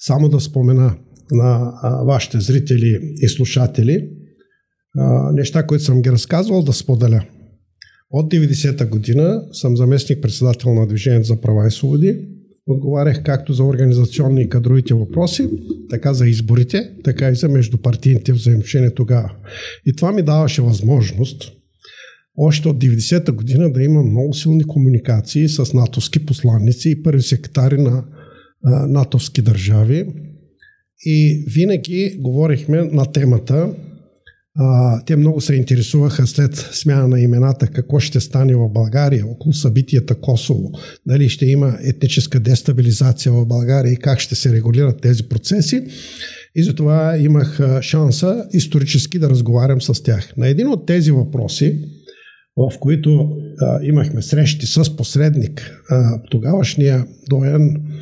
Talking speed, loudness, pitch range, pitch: 125 wpm, -15 LUFS, 125-150 Hz, 135 Hz